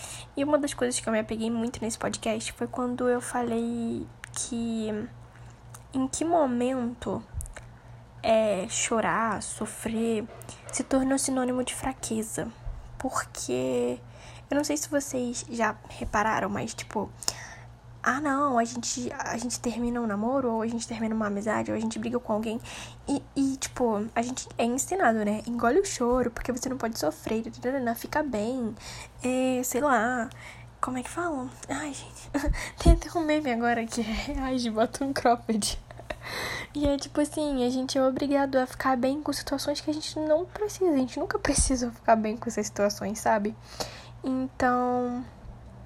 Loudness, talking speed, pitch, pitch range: -28 LUFS, 165 wpm, 245 Hz, 225-270 Hz